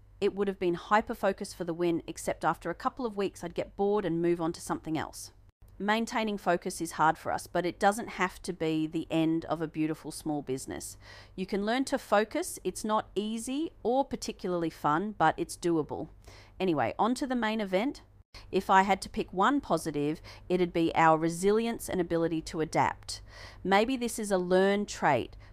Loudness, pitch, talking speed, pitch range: -30 LUFS, 180 Hz, 195 wpm, 160-210 Hz